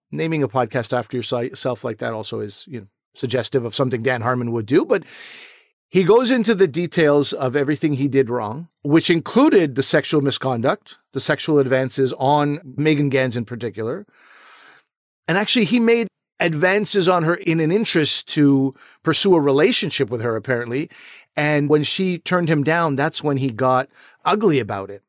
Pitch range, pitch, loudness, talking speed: 130-170 Hz, 145 Hz, -19 LUFS, 170 wpm